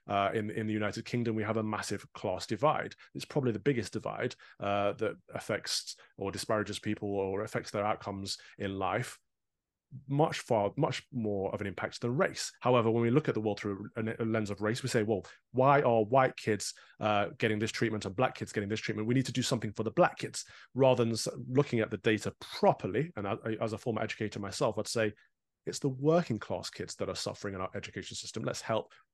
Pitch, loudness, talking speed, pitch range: 110 Hz, -33 LUFS, 220 wpm, 105-120 Hz